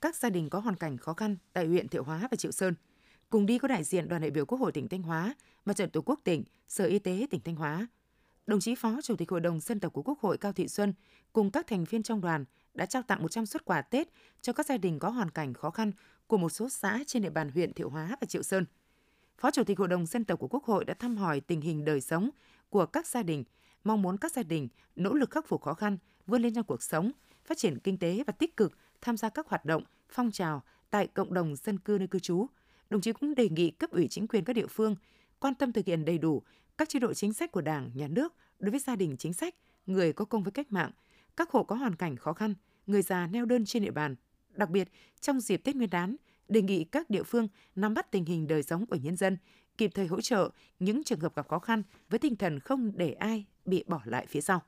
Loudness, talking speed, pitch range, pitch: -32 LUFS, 265 wpm, 170-235 Hz, 200 Hz